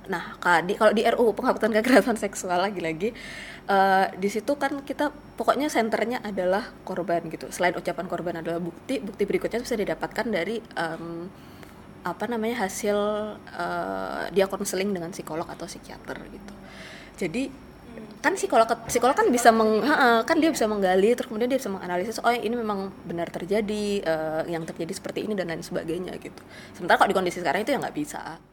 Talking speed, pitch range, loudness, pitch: 170 wpm, 175-230 Hz, -25 LUFS, 205 Hz